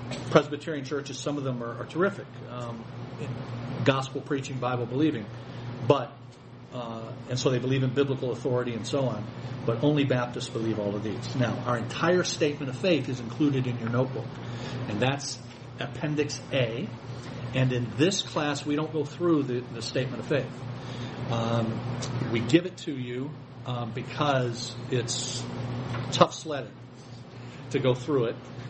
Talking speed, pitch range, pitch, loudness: 160 wpm, 120-140 Hz, 125 Hz, -29 LUFS